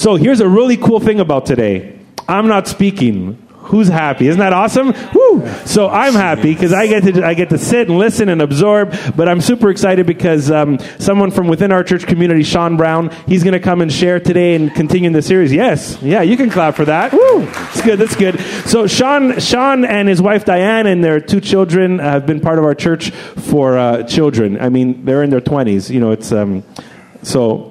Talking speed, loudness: 215 wpm, -12 LUFS